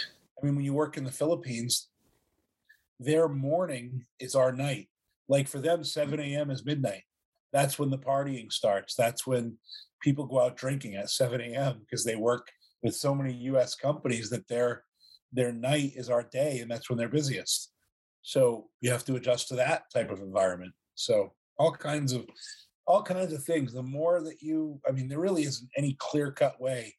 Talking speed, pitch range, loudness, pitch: 190 wpm, 125-150 Hz, -30 LUFS, 135 Hz